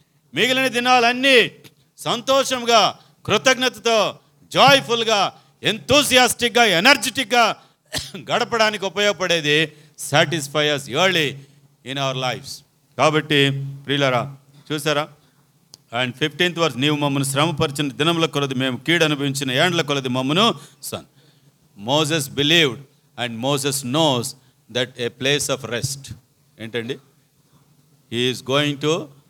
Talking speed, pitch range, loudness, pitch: 95 wpm, 140-170 Hz, -19 LUFS, 145 Hz